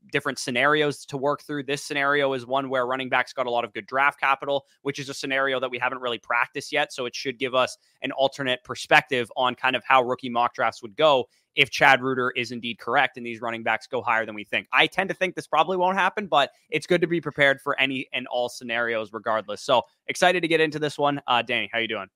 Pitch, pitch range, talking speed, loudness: 135 Hz, 125-145 Hz, 250 wpm, -24 LUFS